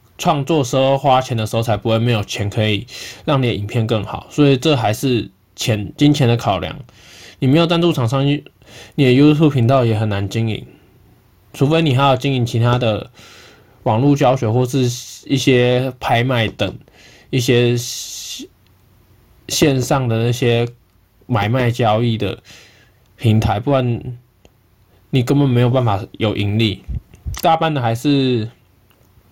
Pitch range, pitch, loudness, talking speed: 110-135 Hz, 120 Hz, -17 LUFS, 225 characters per minute